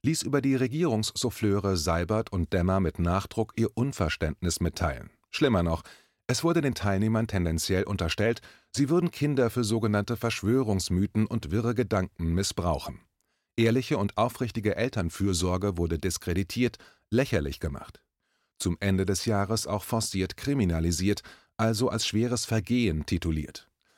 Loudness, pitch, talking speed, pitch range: -28 LUFS, 105 Hz, 125 wpm, 90-115 Hz